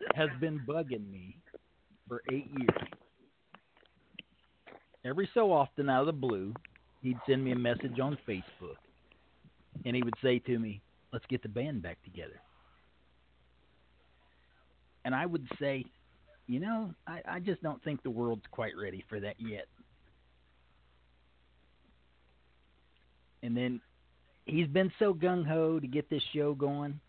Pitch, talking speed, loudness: 120 Hz, 140 wpm, -34 LUFS